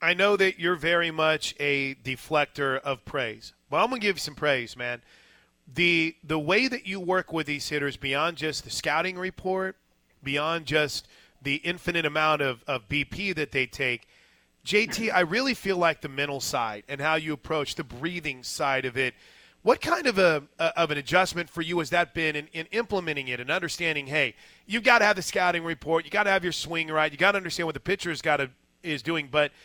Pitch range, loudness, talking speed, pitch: 145-180 Hz, -26 LUFS, 215 wpm, 160 Hz